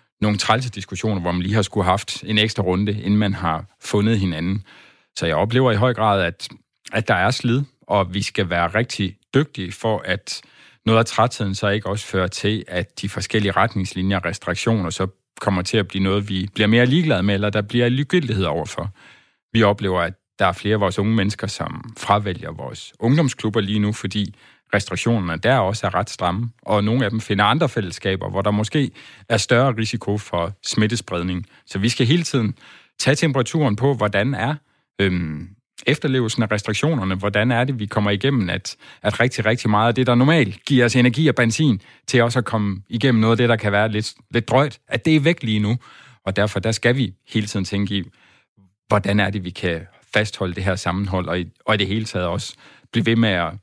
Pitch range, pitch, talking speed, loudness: 95-120 Hz, 105 Hz, 210 wpm, -20 LUFS